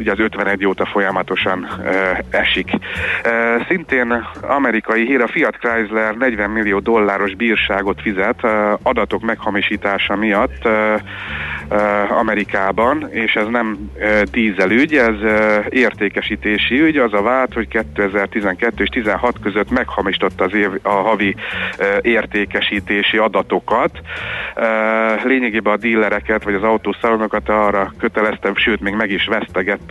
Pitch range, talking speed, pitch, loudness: 100-115 Hz, 130 wpm, 105 Hz, -16 LUFS